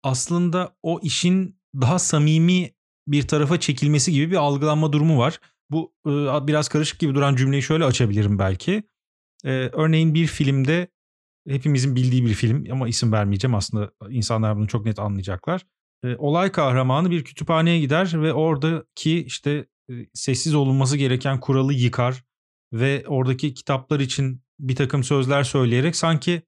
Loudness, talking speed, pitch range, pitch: -21 LUFS, 135 wpm, 130-160 Hz, 145 Hz